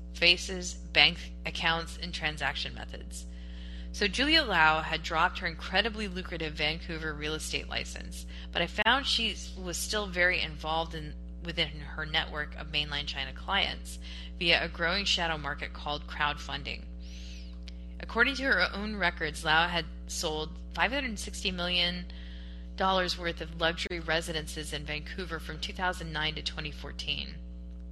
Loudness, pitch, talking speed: -30 LUFS, 150 Hz, 135 wpm